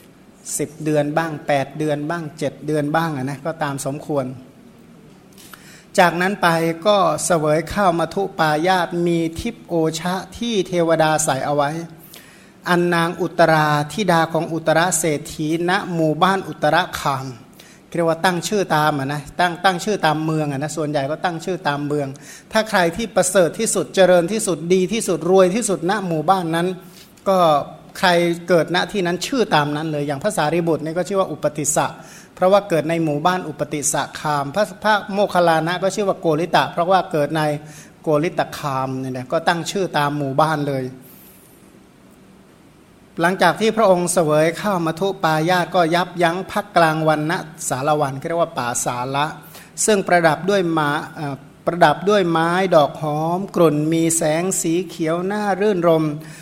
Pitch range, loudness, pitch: 150-185 Hz, -19 LUFS, 165 Hz